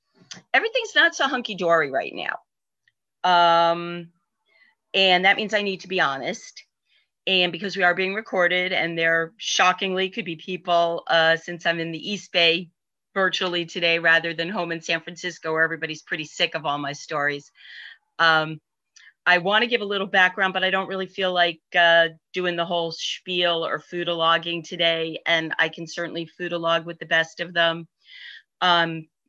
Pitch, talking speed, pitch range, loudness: 170 Hz, 175 wpm, 165-185 Hz, -22 LUFS